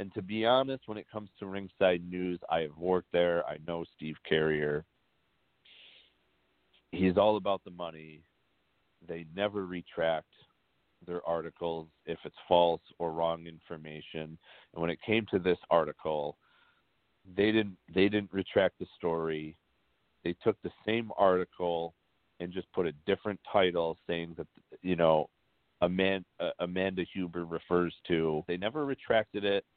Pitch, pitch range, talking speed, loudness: 90 Hz, 80-100 Hz, 145 wpm, -32 LUFS